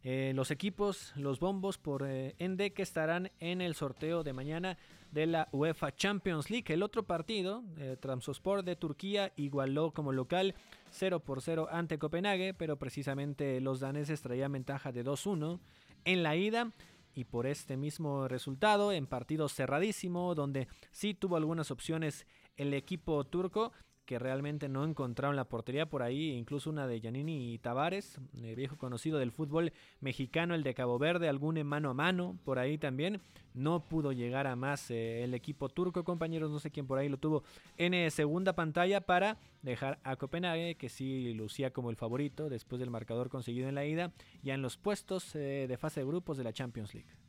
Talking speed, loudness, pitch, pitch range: 185 wpm, -36 LUFS, 150 Hz, 135-175 Hz